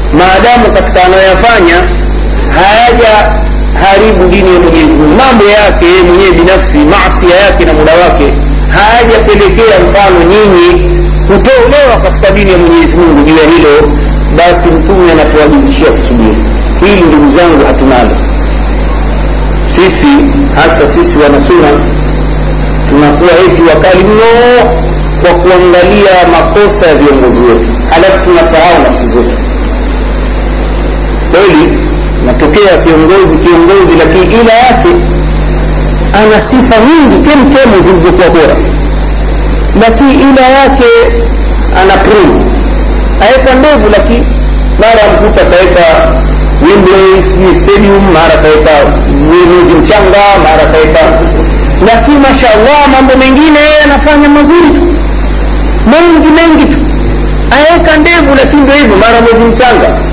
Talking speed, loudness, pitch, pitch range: 105 wpm, -4 LUFS, 205 Hz, 170-280 Hz